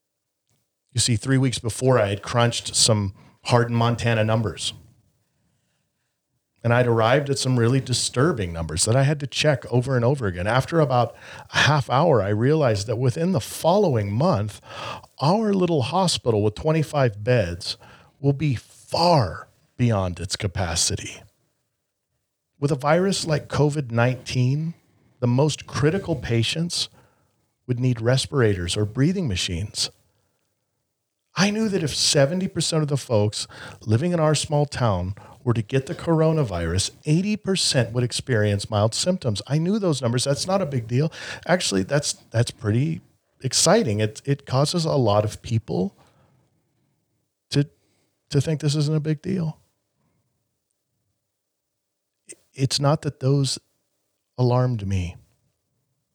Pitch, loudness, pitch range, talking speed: 125 Hz, -22 LUFS, 110-150 Hz, 135 wpm